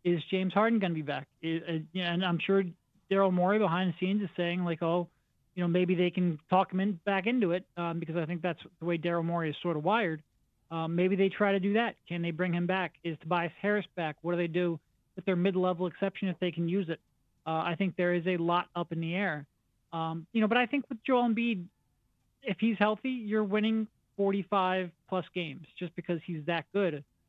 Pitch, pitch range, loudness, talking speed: 180 Hz, 170-195 Hz, -31 LUFS, 235 wpm